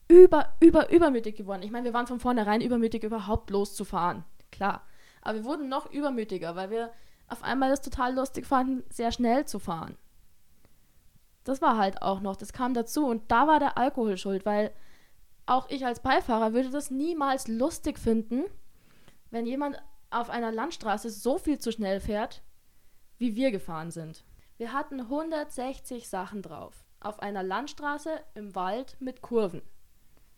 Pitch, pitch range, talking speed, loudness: 240 Hz, 210-275 Hz, 160 wpm, -28 LUFS